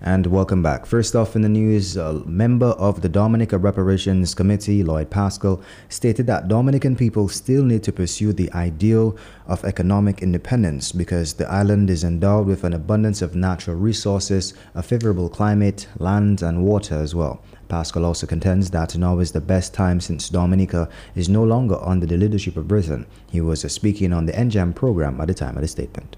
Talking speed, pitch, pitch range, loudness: 185 wpm, 95 Hz, 85-105 Hz, -20 LUFS